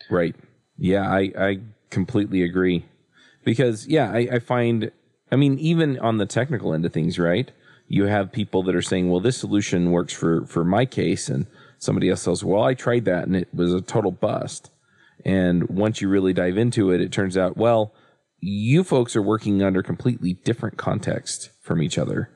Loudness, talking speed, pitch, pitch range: -22 LUFS, 190 wpm, 100 Hz, 90-120 Hz